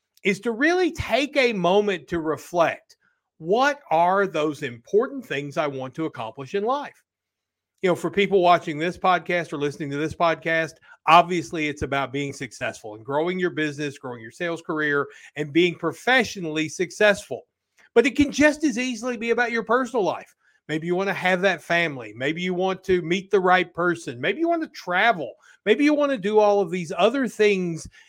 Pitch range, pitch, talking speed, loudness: 155-210 Hz, 175 Hz, 185 wpm, -23 LUFS